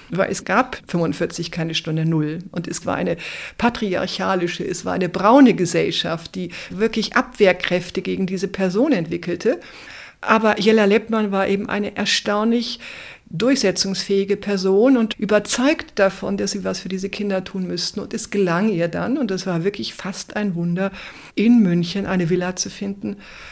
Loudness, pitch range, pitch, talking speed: -20 LUFS, 180-215 Hz, 195 Hz, 160 wpm